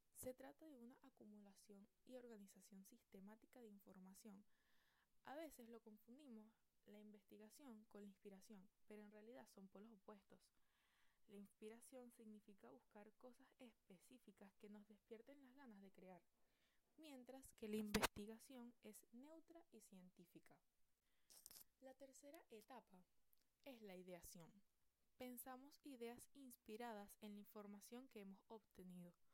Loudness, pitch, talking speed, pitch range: -60 LUFS, 220 Hz, 125 wpm, 205-255 Hz